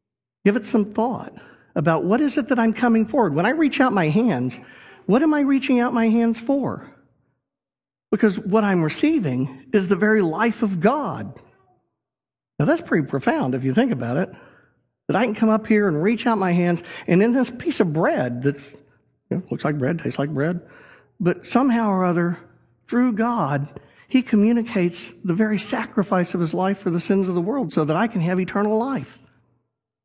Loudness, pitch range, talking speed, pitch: -21 LUFS, 170-235 Hz, 195 wpm, 210 Hz